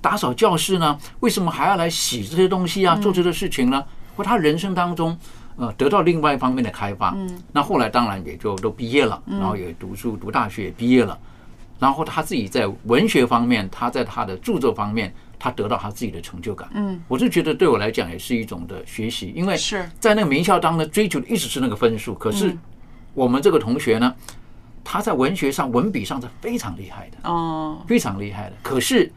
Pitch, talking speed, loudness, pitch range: 145 Hz, 325 characters per minute, -21 LUFS, 115-180 Hz